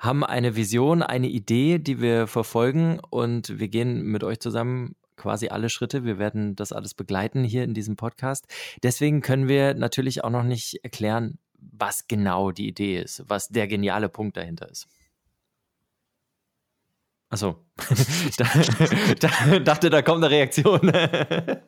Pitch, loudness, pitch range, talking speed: 120 Hz, -23 LUFS, 110-145 Hz, 145 wpm